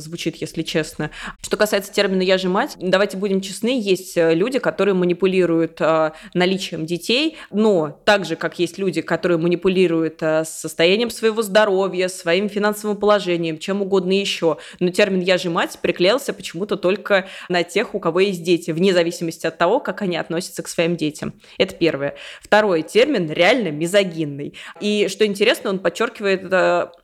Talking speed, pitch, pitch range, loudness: 160 wpm, 185 Hz, 170-200 Hz, -19 LUFS